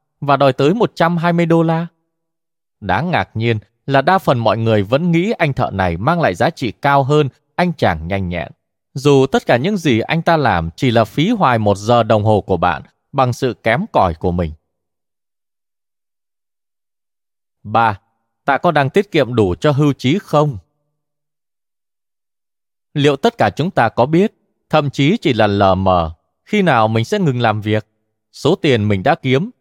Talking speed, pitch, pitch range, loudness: 180 wpm, 135 Hz, 110-160 Hz, -15 LUFS